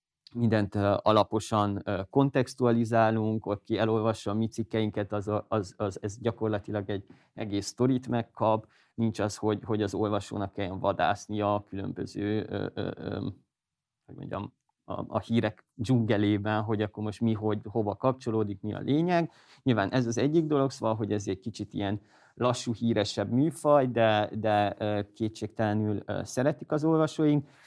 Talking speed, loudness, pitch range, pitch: 135 wpm, -29 LUFS, 105-120 Hz, 110 Hz